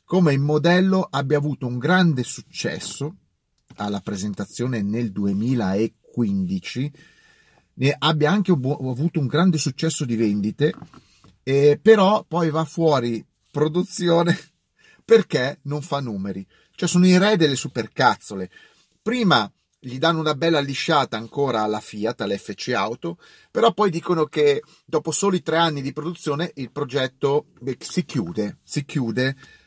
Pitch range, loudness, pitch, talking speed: 120-170 Hz, -22 LUFS, 145 Hz, 135 wpm